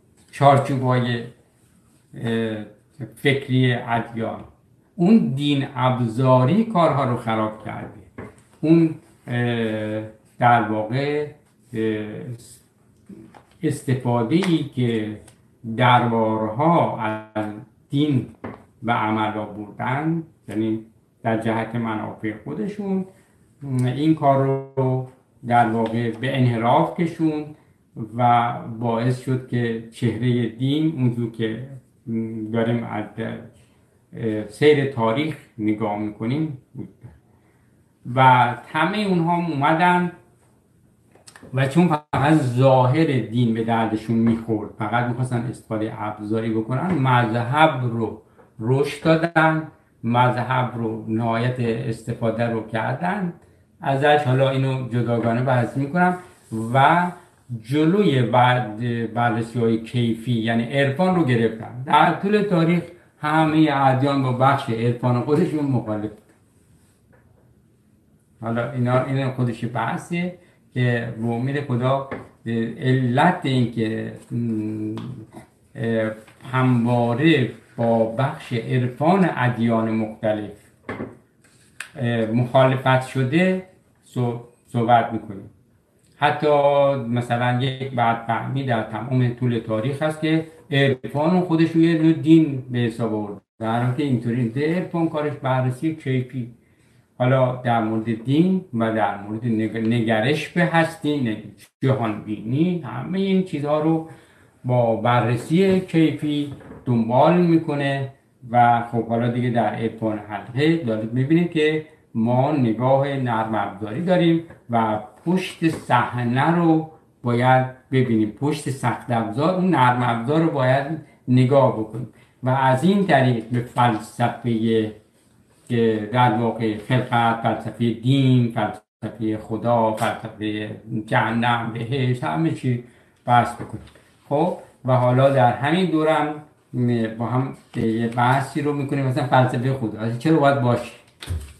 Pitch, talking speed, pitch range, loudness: 120 Hz, 105 wpm, 115-140 Hz, -21 LUFS